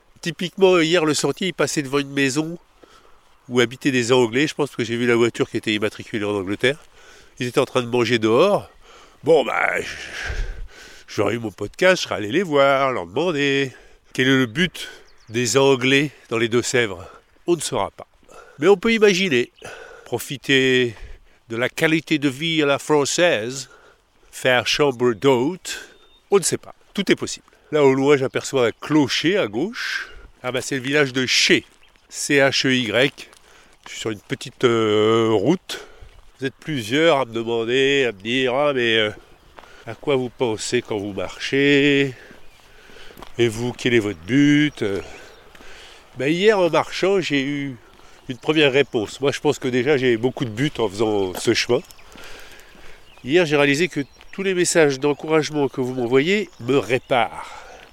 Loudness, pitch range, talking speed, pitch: -20 LUFS, 120-150 Hz, 175 wpm, 135 Hz